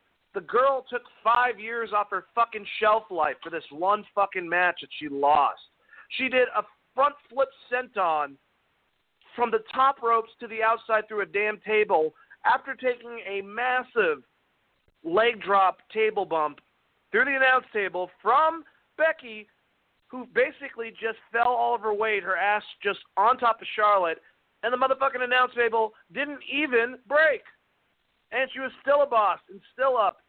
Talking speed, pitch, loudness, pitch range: 160 wpm, 230 Hz, -25 LUFS, 205-260 Hz